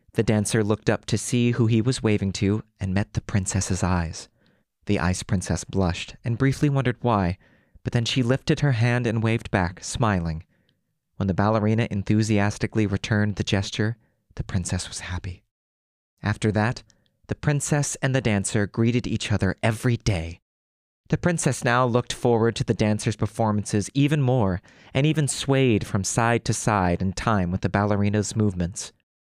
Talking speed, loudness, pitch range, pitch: 165 wpm, -24 LUFS, 100-120 Hz, 110 Hz